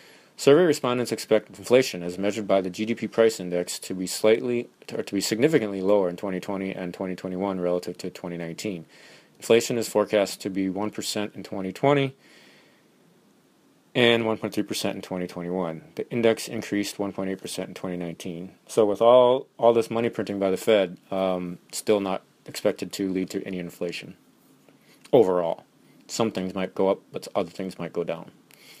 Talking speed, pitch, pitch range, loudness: 160 wpm, 100 Hz, 95-110 Hz, -25 LUFS